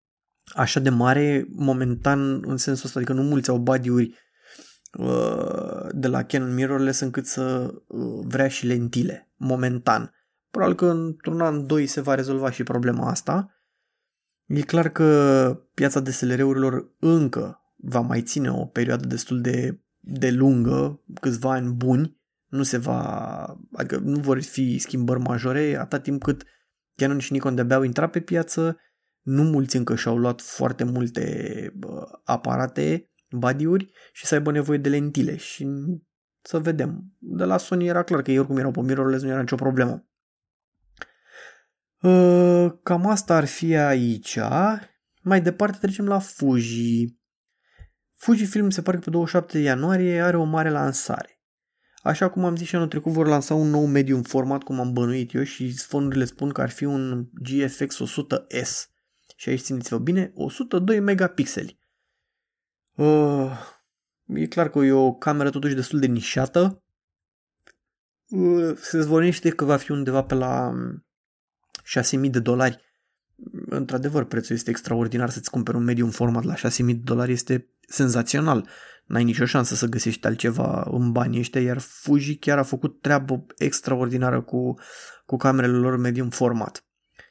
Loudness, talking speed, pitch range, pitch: -23 LUFS, 150 wpm, 125-160 Hz, 135 Hz